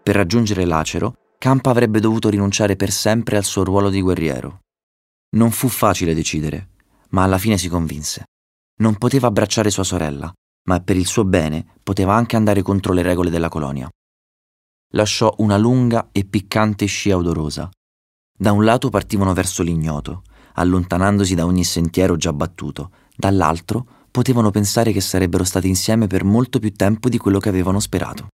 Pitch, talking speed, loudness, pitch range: 95 Hz, 160 wpm, -18 LUFS, 85-105 Hz